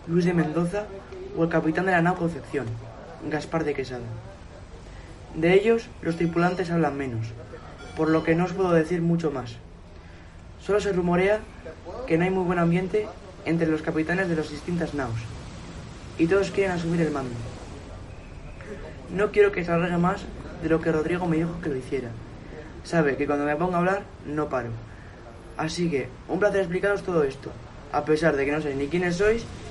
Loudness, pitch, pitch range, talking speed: -25 LUFS, 160 Hz, 120-175 Hz, 180 wpm